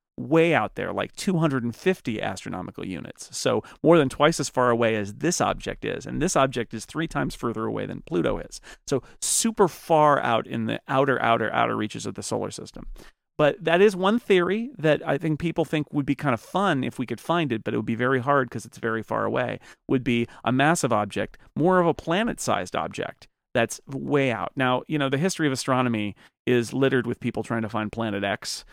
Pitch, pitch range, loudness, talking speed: 135 Hz, 115-160 Hz, -24 LUFS, 215 wpm